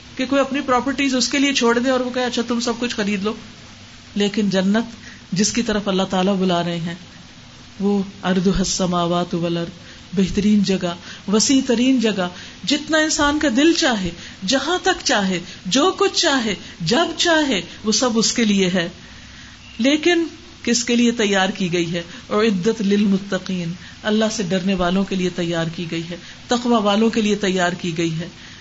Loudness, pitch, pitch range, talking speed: -19 LUFS, 210 Hz, 185-250 Hz, 180 wpm